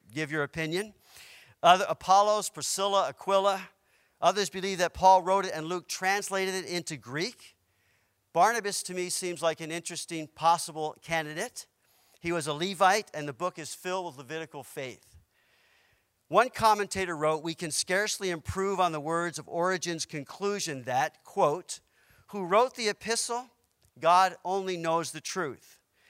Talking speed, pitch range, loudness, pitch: 145 wpm, 160-195 Hz, -29 LUFS, 180 Hz